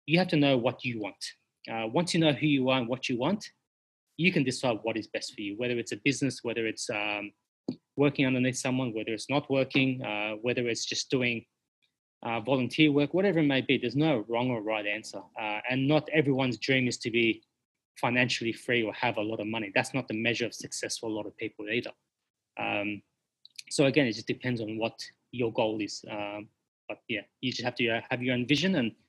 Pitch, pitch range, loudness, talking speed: 125 Hz, 110-135 Hz, -29 LUFS, 230 wpm